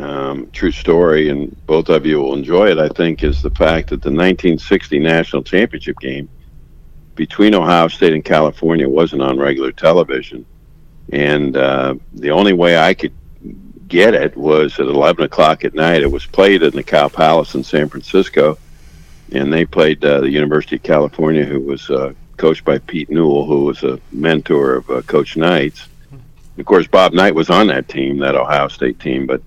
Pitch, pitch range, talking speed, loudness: 75 Hz, 70-80 Hz, 185 wpm, -14 LUFS